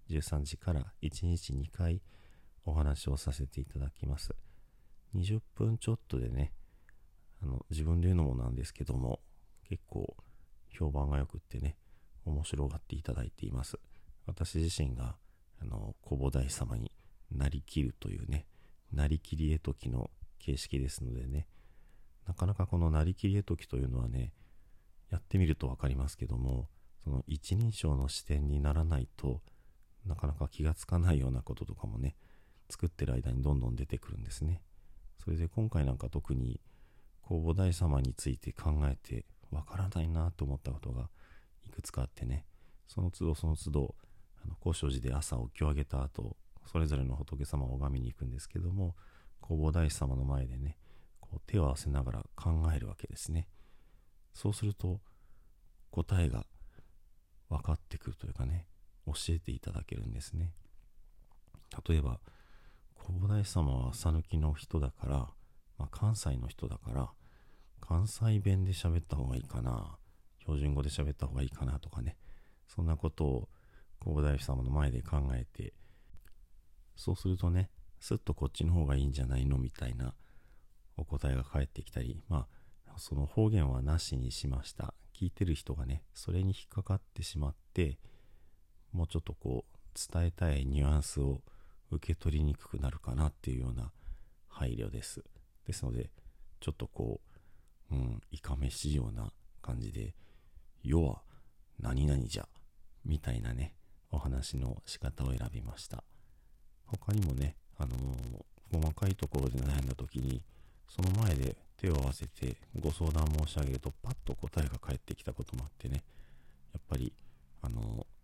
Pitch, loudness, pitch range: 75 Hz, -37 LUFS, 70-90 Hz